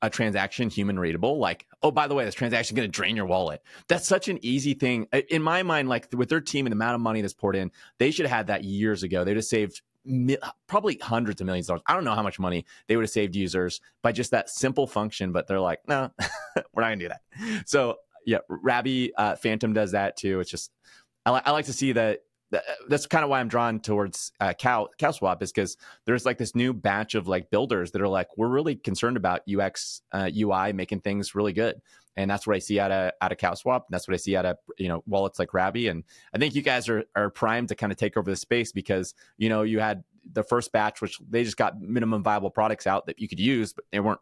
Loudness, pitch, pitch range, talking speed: -26 LUFS, 110 Hz, 100-125 Hz, 255 wpm